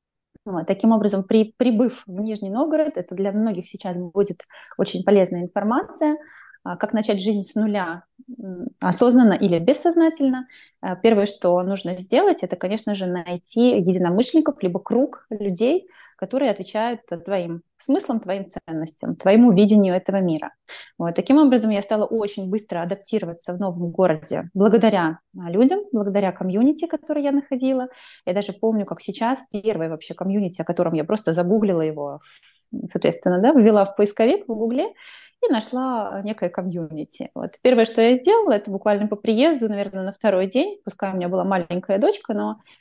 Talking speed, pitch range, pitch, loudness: 150 wpm, 185-245 Hz, 210 Hz, -21 LUFS